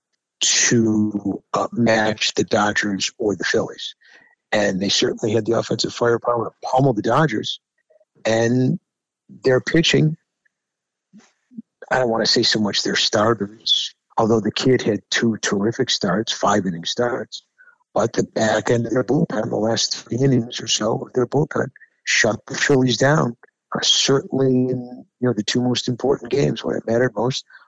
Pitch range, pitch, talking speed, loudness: 110-135 Hz, 125 Hz, 155 wpm, -19 LUFS